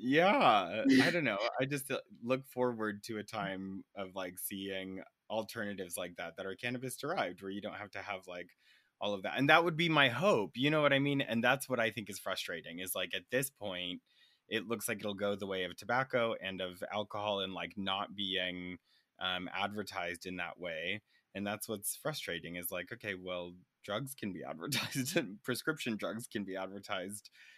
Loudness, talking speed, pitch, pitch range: -35 LUFS, 200 wpm, 105 Hz, 95-125 Hz